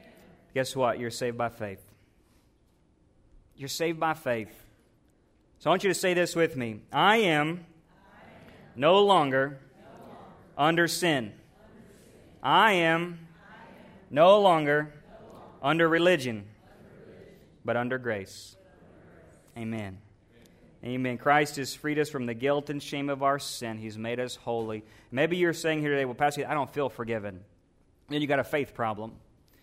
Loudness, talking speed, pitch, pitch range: -27 LUFS, 145 wpm, 135 Hz, 115-160 Hz